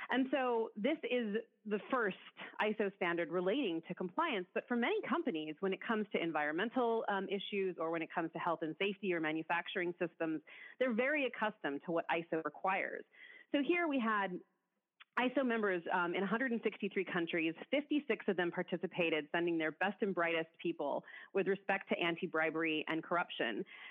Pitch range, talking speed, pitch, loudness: 170-230 Hz, 170 wpm, 190 Hz, -37 LUFS